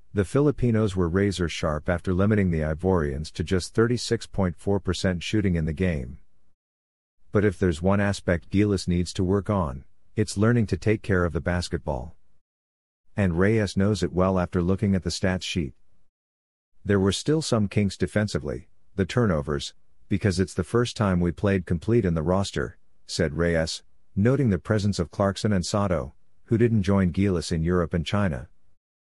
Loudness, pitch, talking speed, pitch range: -25 LUFS, 95 Hz, 165 wpm, 85-100 Hz